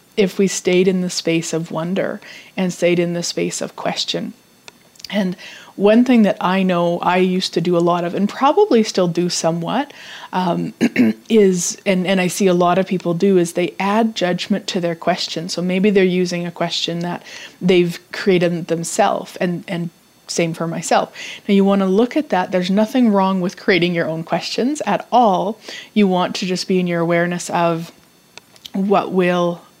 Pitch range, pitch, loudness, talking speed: 175-200 Hz, 185 Hz, -18 LUFS, 190 wpm